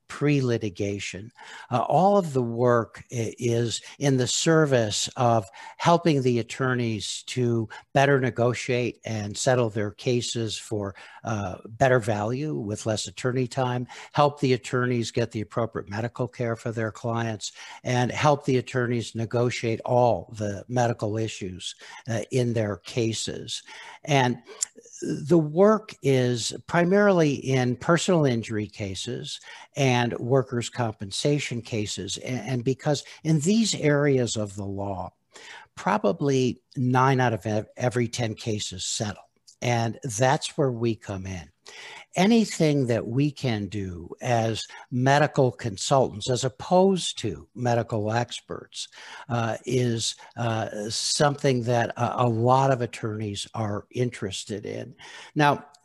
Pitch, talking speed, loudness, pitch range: 120 Hz, 125 wpm, -25 LUFS, 110-135 Hz